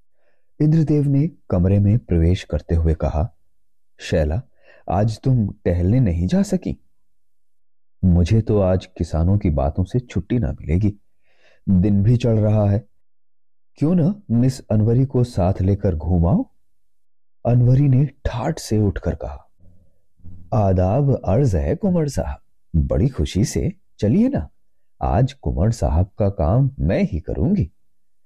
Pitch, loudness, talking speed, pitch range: 100 Hz, -20 LUFS, 135 wpm, 90-120 Hz